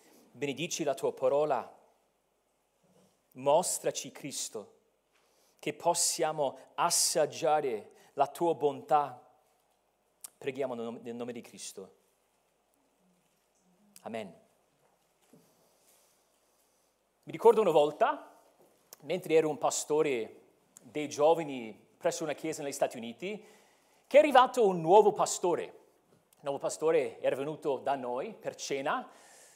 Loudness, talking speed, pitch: -30 LUFS, 100 wpm, 180 Hz